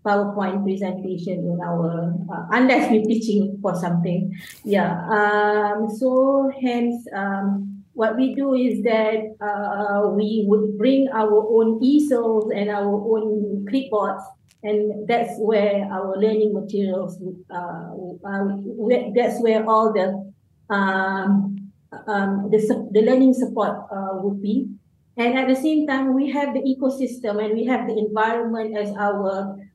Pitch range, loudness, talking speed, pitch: 195-235 Hz, -21 LUFS, 135 wpm, 210 Hz